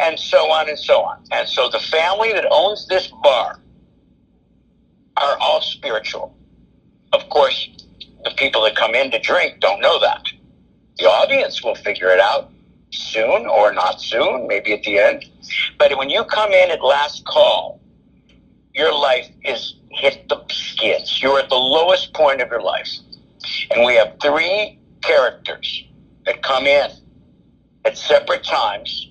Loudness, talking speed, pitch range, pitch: -17 LUFS, 155 wpm, 270-295 Hz, 285 Hz